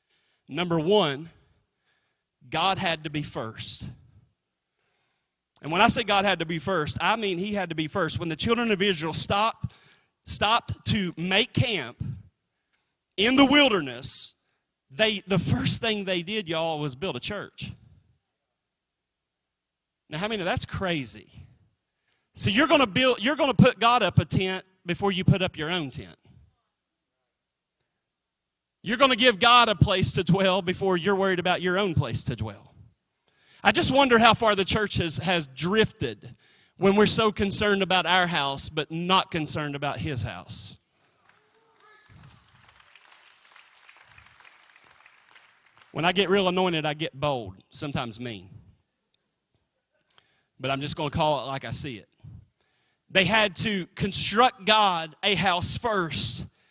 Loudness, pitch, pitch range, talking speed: -23 LUFS, 180 Hz, 145-205 Hz, 150 wpm